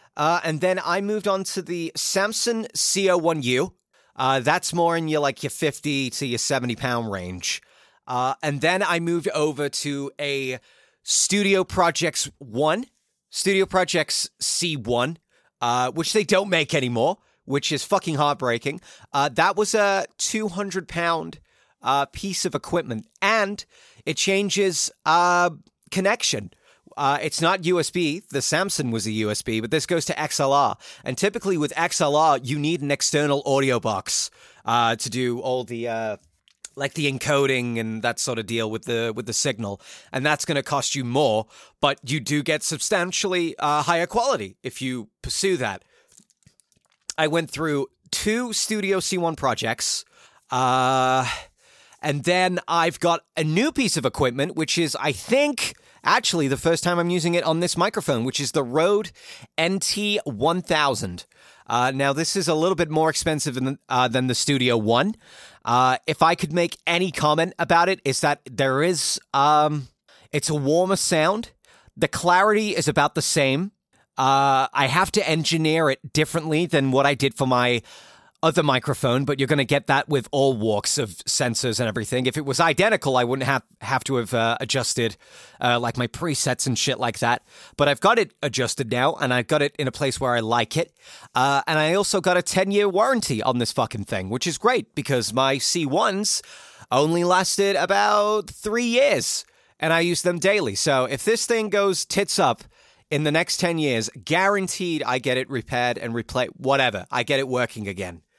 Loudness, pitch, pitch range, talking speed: -22 LUFS, 150 Hz, 130-175 Hz, 180 wpm